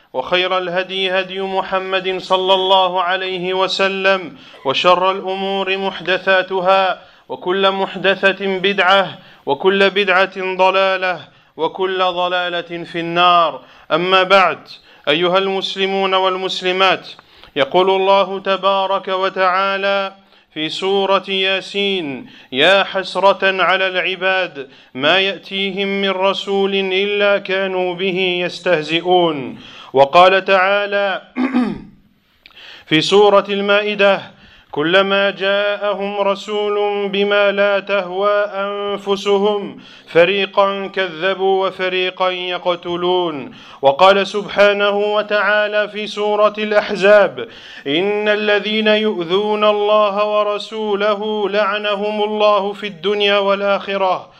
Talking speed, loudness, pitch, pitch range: 85 wpm, -16 LUFS, 195 Hz, 185-200 Hz